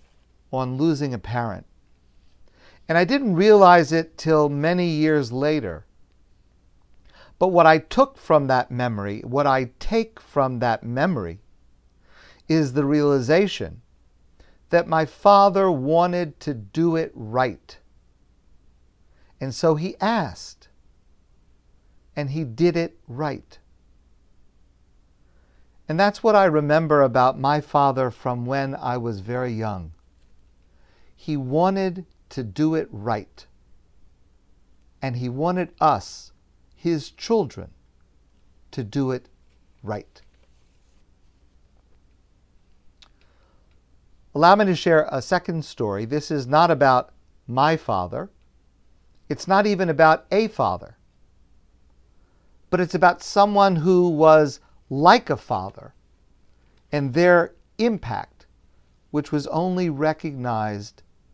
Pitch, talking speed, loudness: 125 Hz, 110 wpm, -21 LUFS